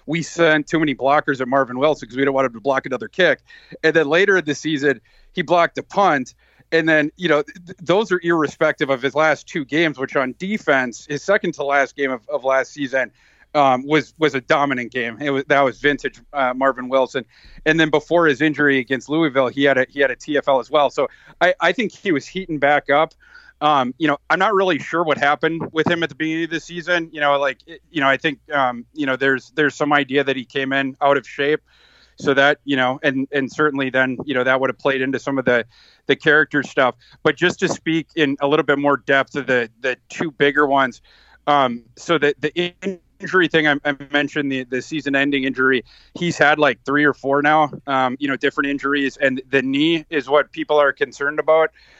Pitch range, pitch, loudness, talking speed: 135-155 Hz, 145 Hz, -19 LUFS, 230 wpm